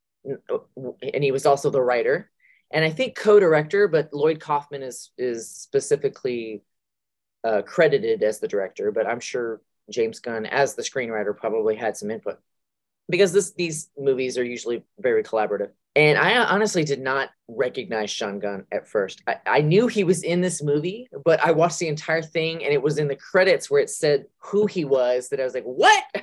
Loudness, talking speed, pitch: -22 LUFS, 190 wpm, 165 Hz